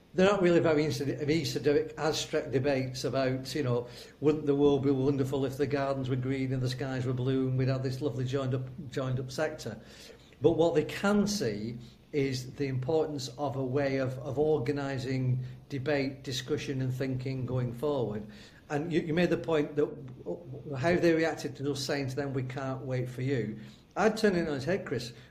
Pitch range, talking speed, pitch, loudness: 130-150 Hz, 200 wpm, 140 Hz, -31 LUFS